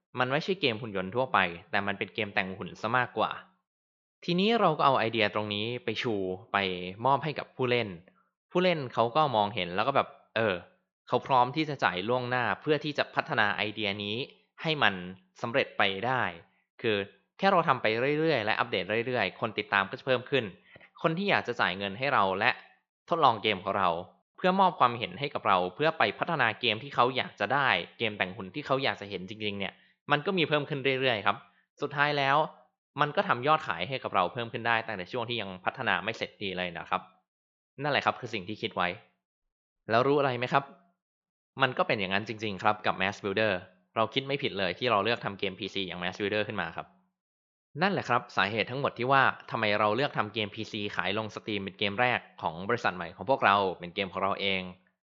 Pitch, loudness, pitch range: 110 Hz, -29 LUFS, 100-135 Hz